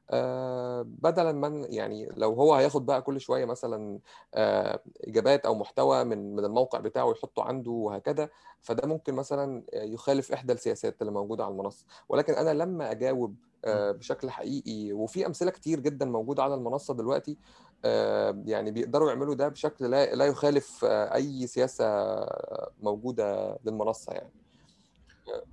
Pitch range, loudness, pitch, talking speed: 115-150 Hz, -29 LUFS, 135 Hz, 135 wpm